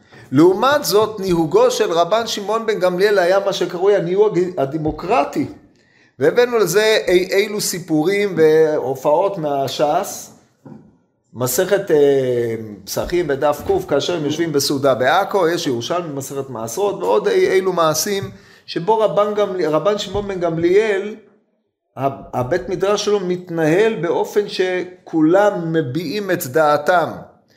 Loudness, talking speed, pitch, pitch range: -17 LUFS, 115 wpm, 185 Hz, 155-210 Hz